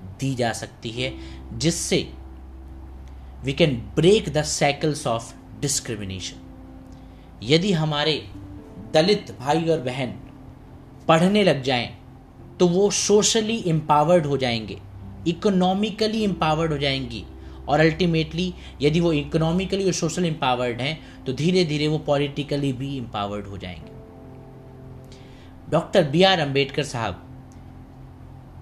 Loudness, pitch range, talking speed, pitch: -22 LUFS, 115-160 Hz, 115 wpm, 135 Hz